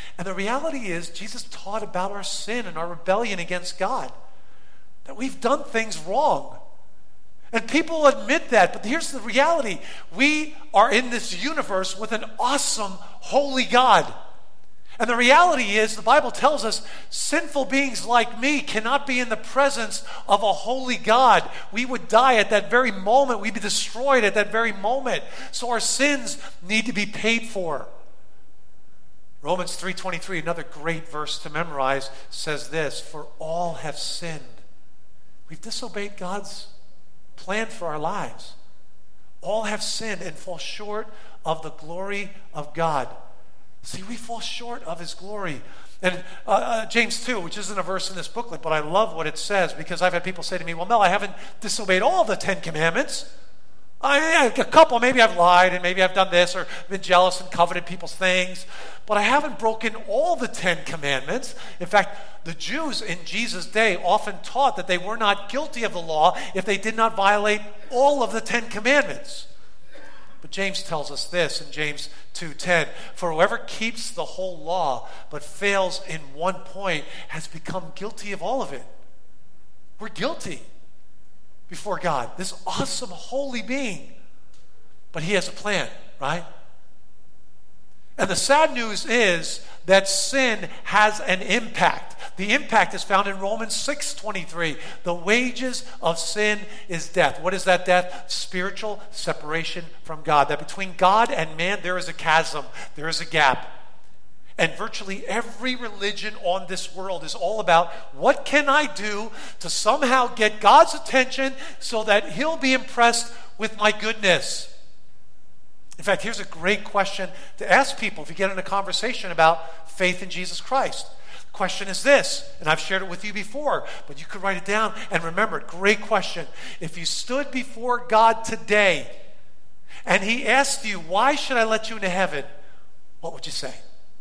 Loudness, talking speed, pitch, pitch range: -22 LUFS, 170 wpm, 200 Hz, 175-235 Hz